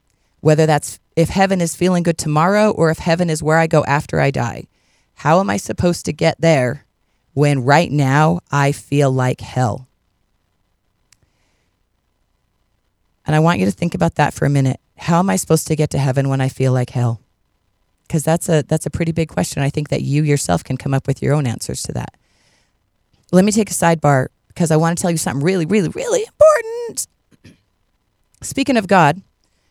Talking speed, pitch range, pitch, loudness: 195 wpm, 130-170 Hz, 150 Hz, -17 LUFS